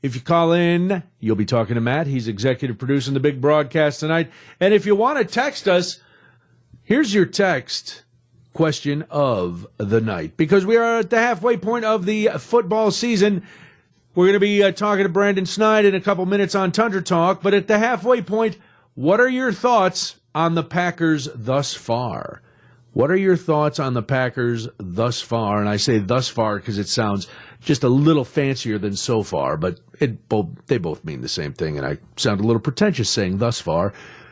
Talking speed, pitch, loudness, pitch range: 200 wpm, 155 Hz, -20 LUFS, 120-200 Hz